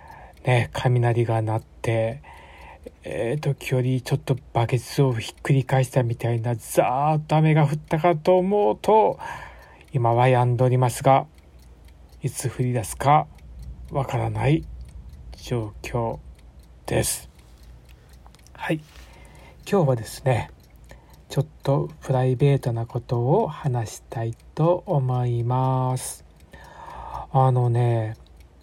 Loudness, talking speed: -23 LUFS, 215 characters per minute